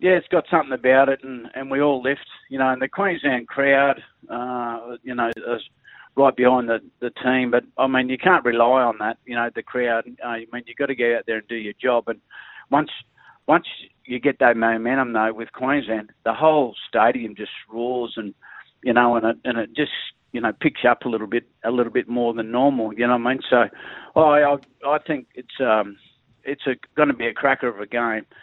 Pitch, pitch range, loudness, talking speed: 125 Hz, 115-135 Hz, -21 LUFS, 230 wpm